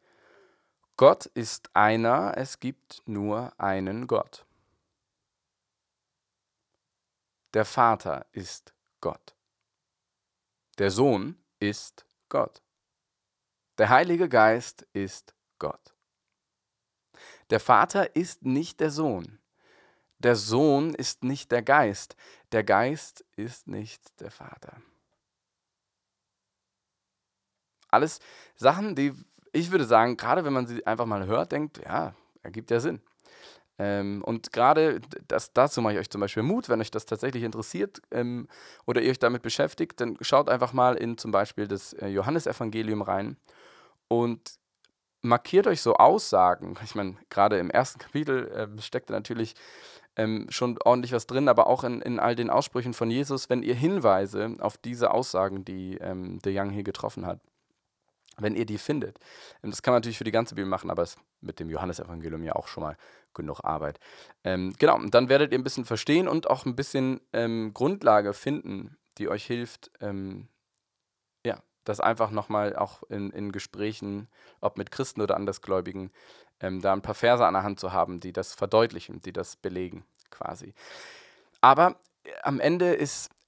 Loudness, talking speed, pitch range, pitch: -26 LUFS, 150 wpm, 100-125 Hz, 110 Hz